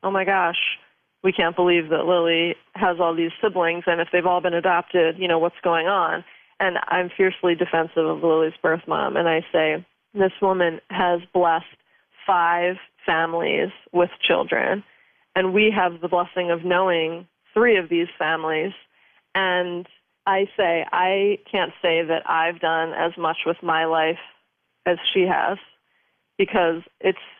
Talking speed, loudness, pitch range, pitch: 160 wpm, -21 LUFS, 165-185 Hz, 175 Hz